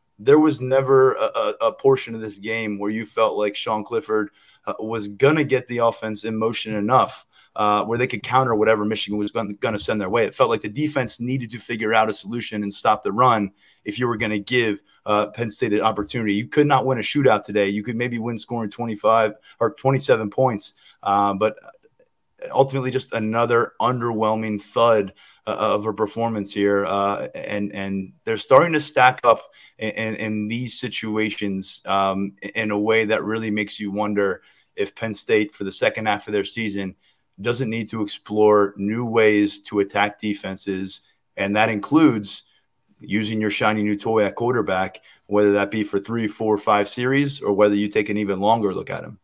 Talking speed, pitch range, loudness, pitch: 195 wpm, 105-120 Hz, -21 LUFS, 110 Hz